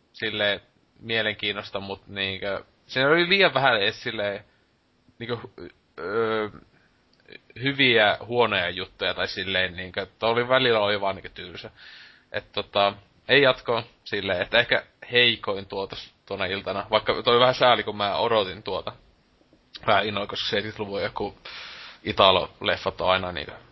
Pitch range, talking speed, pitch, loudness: 100-120 Hz, 125 wpm, 105 Hz, -24 LUFS